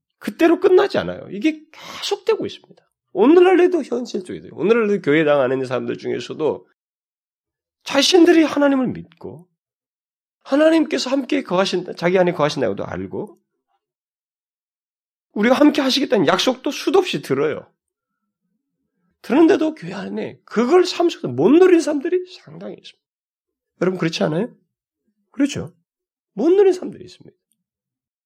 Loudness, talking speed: -18 LUFS, 320 characters per minute